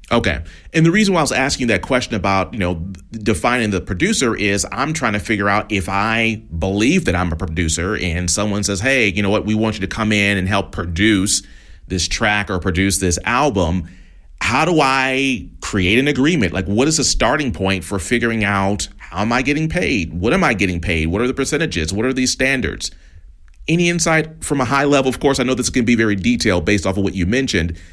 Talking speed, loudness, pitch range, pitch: 225 wpm, -17 LUFS, 90-125 Hz, 105 Hz